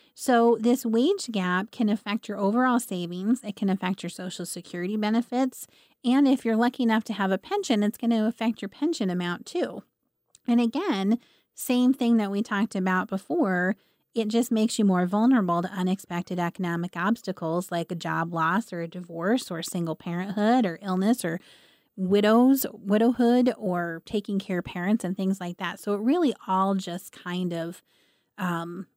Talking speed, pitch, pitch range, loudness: 175 wpm, 205 Hz, 180-235 Hz, -26 LUFS